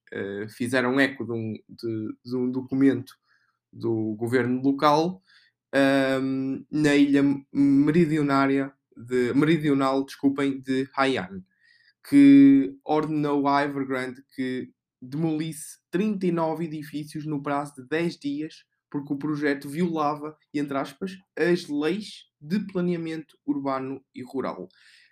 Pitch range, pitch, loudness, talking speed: 135-155 Hz, 140 Hz, -25 LUFS, 110 wpm